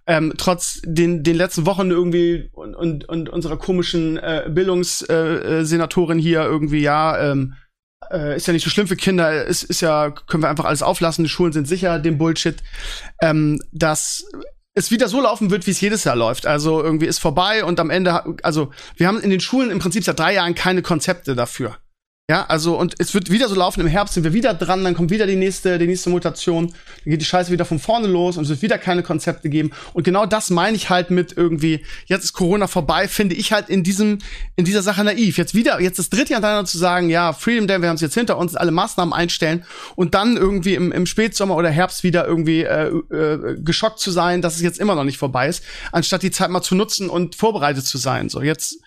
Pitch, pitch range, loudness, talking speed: 175 Hz, 165-190 Hz, -18 LUFS, 230 wpm